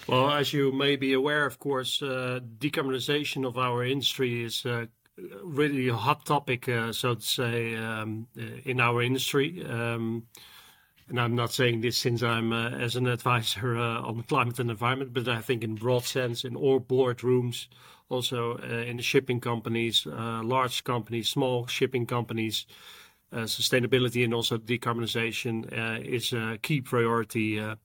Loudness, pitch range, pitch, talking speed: -28 LUFS, 115-130 Hz, 120 Hz, 165 wpm